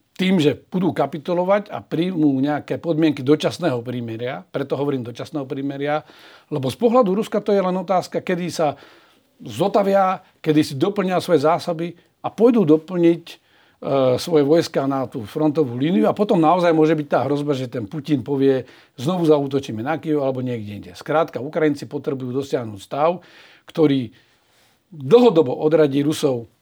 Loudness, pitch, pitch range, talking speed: -20 LUFS, 155 Hz, 135-170 Hz, 150 wpm